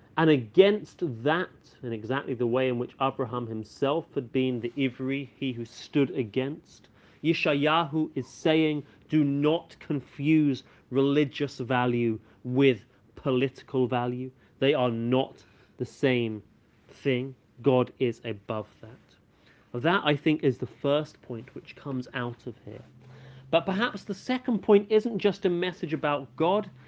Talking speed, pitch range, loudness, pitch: 145 wpm, 120-155 Hz, -27 LUFS, 130 Hz